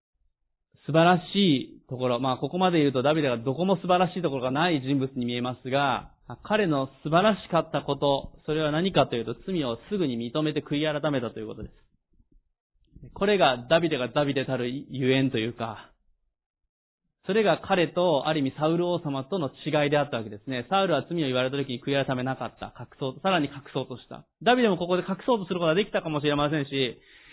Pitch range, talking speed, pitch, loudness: 130-170 Hz, 405 characters per minute, 145 Hz, -26 LUFS